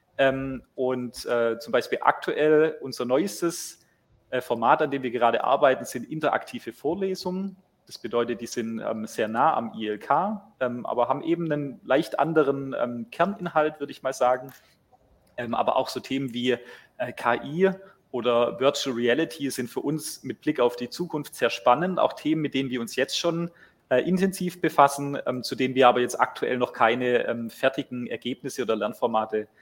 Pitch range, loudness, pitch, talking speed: 120-155 Hz, -26 LUFS, 135 Hz, 150 wpm